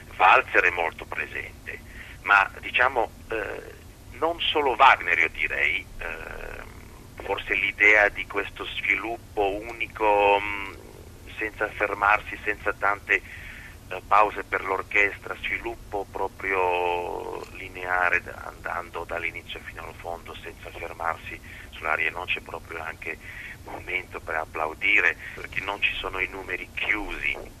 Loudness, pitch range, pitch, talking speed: -24 LUFS, 85-105 Hz, 95 Hz, 115 wpm